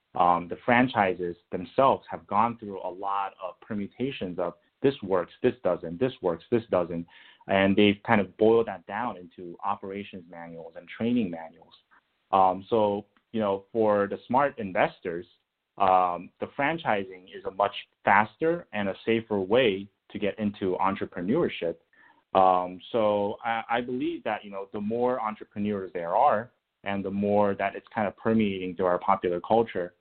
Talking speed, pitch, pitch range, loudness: 160 wpm, 100 Hz, 95-115 Hz, -27 LUFS